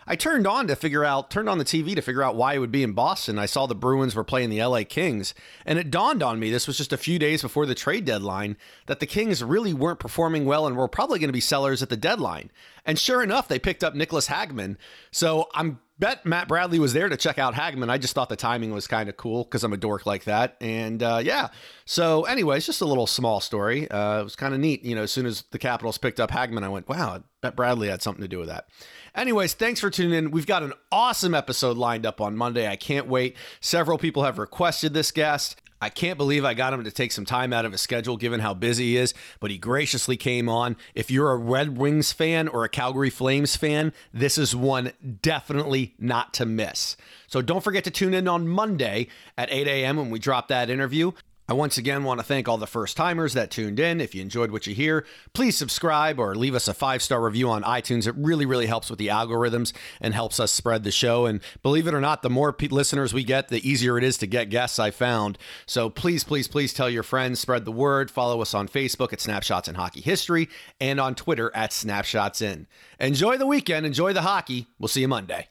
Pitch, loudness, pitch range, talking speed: 130 Hz, -24 LUFS, 115-150 Hz, 245 wpm